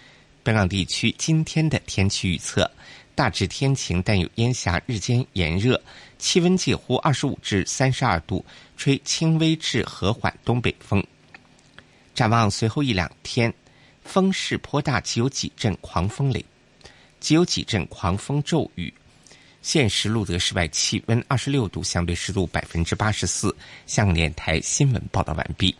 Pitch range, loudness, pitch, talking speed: 95-140 Hz, -23 LUFS, 115 Hz, 235 characters per minute